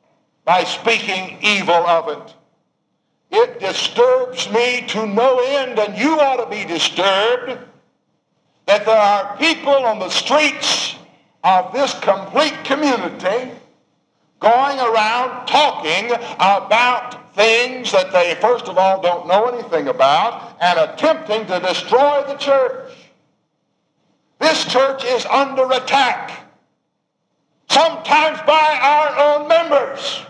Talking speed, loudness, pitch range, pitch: 115 wpm, -16 LUFS, 205-295 Hz, 250 Hz